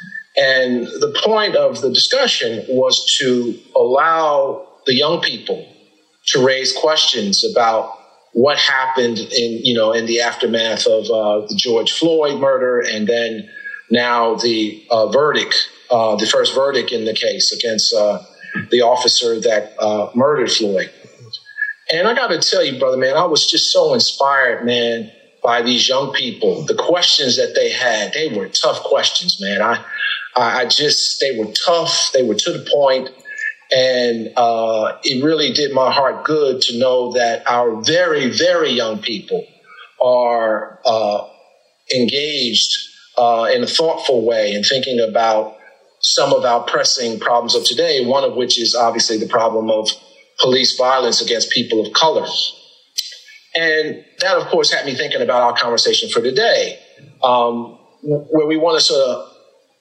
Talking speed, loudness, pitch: 160 wpm, -15 LUFS, 155 Hz